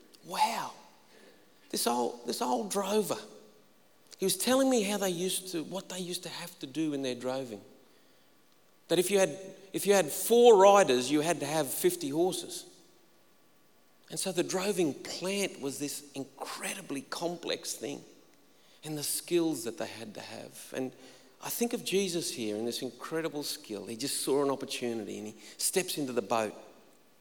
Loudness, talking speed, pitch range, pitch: -31 LUFS, 170 wpm, 130-190 Hz, 165 Hz